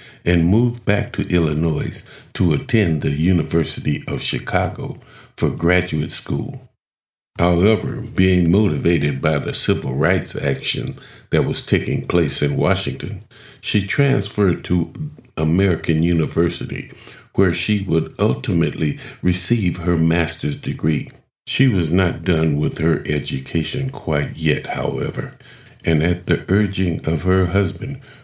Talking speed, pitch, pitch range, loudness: 125 wpm, 90 Hz, 80-105 Hz, -19 LUFS